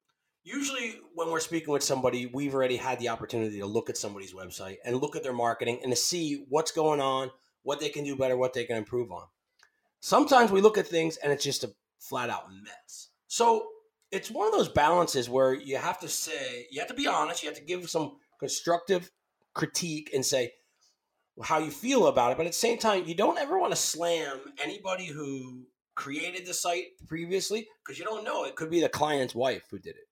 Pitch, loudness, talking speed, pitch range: 150 Hz, -29 LUFS, 215 wpm, 130-180 Hz